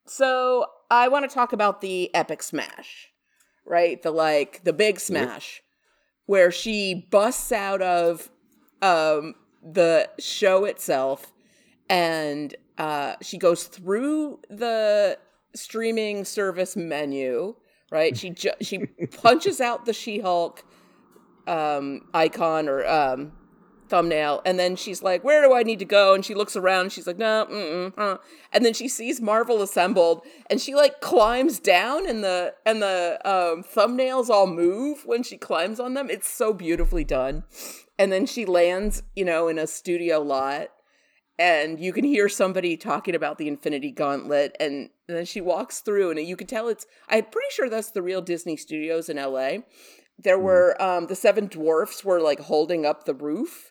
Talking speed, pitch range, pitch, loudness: 160 wpm, 165-220 Hz, 190 Hz, -23 LUFS